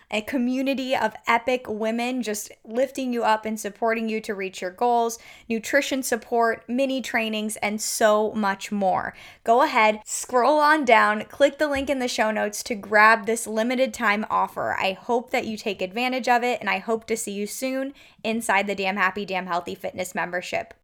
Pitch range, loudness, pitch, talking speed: 210-250 Hz, -23 LUFS, 225 Hz, 185 wpm